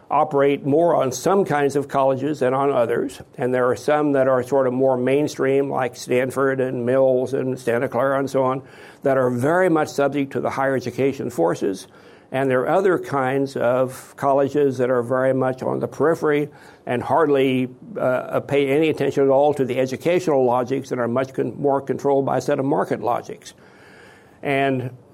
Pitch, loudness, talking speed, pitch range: 135 Hz, -20 LUFS, 190 wpm, 130-140 Hz